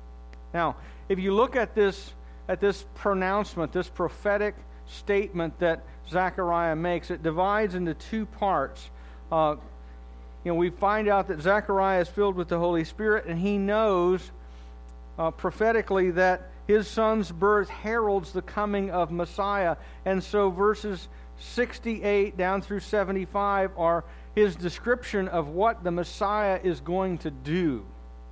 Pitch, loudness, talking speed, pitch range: 185 Hz, -27 LUFS, 140 wpm, 165-205 Hz